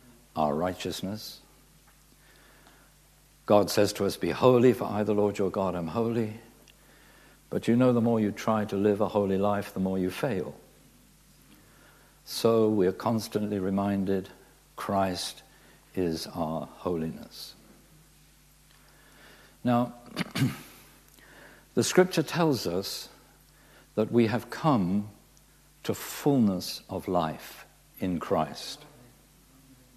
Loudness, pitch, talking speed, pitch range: -28 LUFS, 105 Hz, 110 wpm, 95-115 Hz